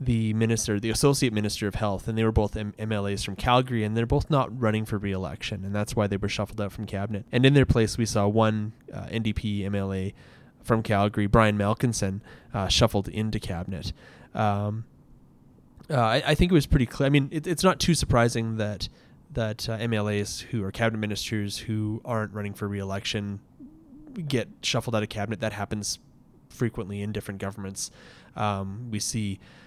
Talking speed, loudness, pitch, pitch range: 185 wpm, -26 LUFS, 110 Hz, 100-115 Hz